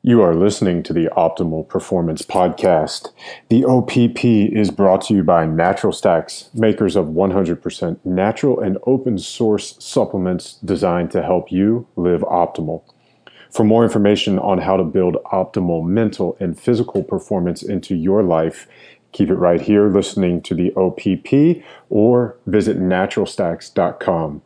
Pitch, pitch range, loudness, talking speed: 100 Hz, 90-115 Hz, -17 LUFS, 140 wpm